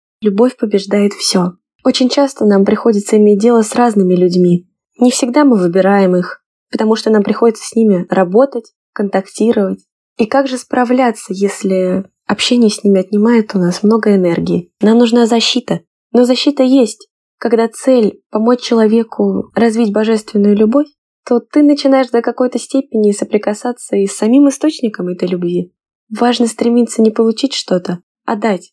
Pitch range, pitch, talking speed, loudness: 200-245 Hz, 225 Hz, 150 wpm, -12 LUFS